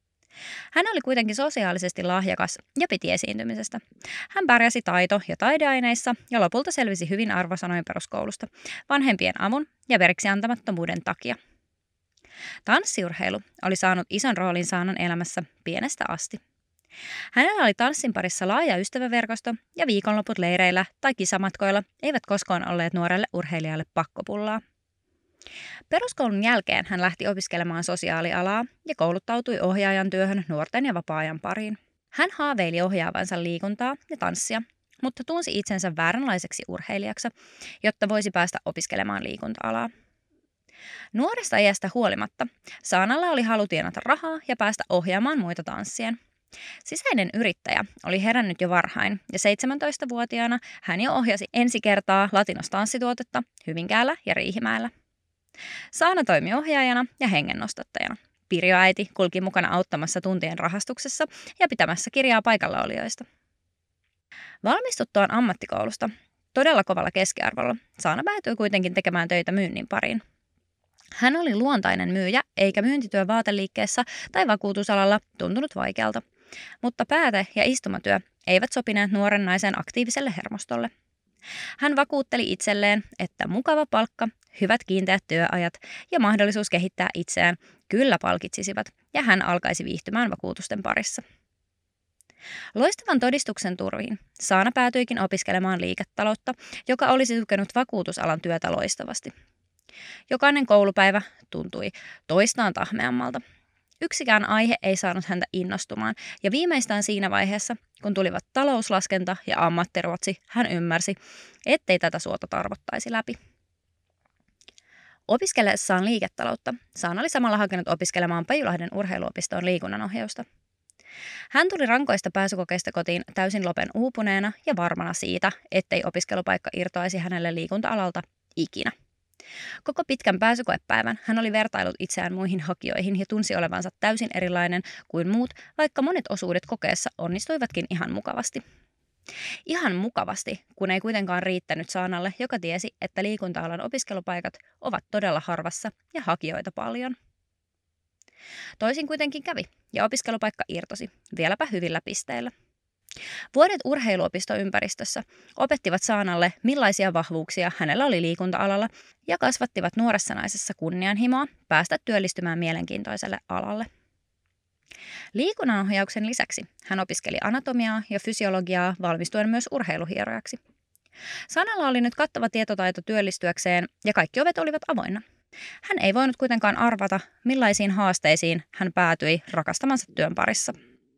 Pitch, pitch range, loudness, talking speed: 200 Hz, 180-240 Hz, -25 LUFS, 115 wpm